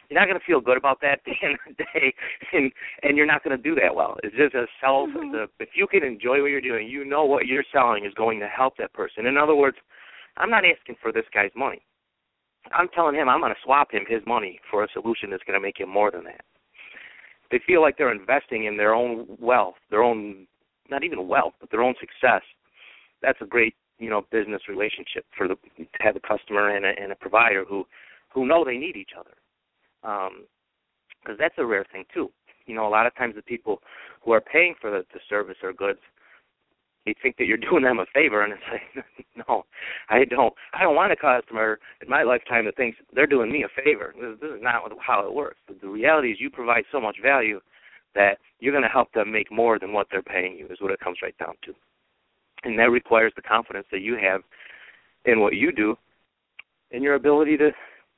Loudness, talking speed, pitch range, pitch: -23 LUFS, 230 wpm, 105-140 Hz, 115 Hz